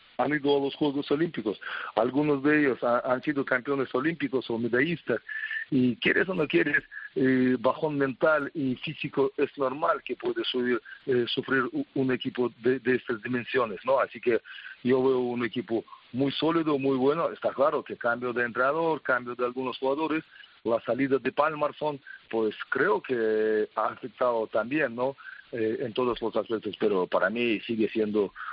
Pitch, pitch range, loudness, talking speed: 130 Hz, 120-145 Hz, -27 LUFS, 170 wpm